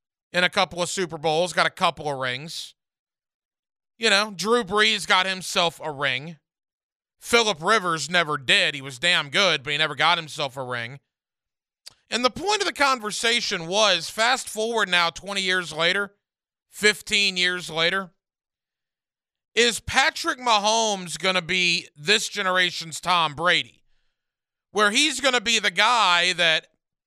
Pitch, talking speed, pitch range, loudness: 185 Hz, 150 wpm, 165-215 Hz, -21 LUFS